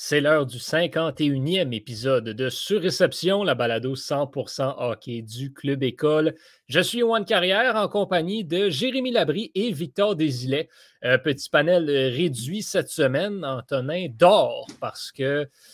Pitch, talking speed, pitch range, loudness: 155 Hz, 135 wpm, 135-190 Hz, -23 LUFS